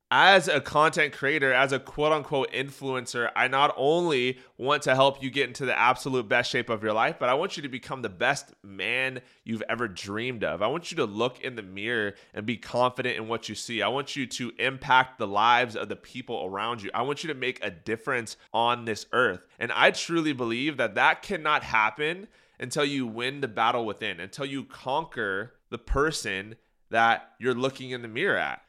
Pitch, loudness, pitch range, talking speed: 125 Hz, -26 LUFS, 115-135 Hz, 210 wpm